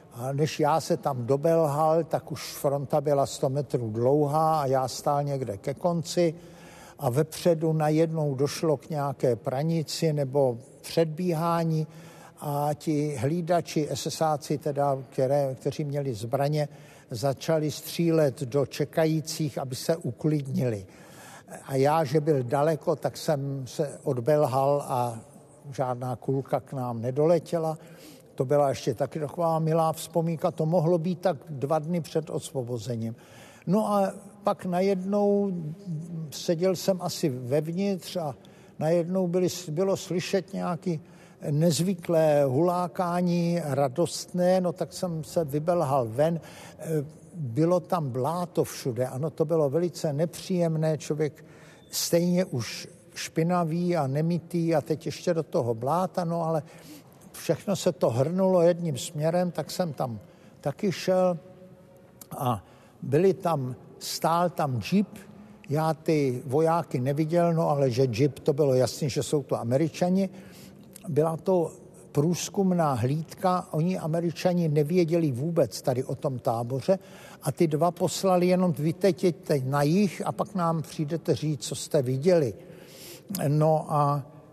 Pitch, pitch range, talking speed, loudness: 160 Hz, 145-175 Hz, 130 wpm, -27 LUFS